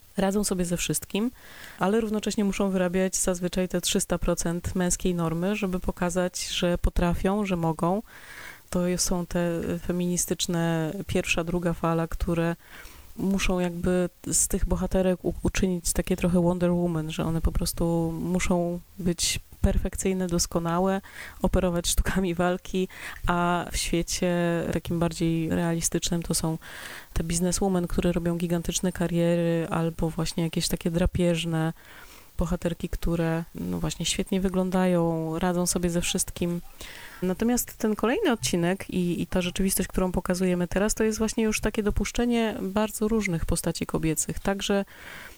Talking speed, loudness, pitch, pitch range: 130 wpm, -26 LUFS, 180 Hz, 170-190 Hz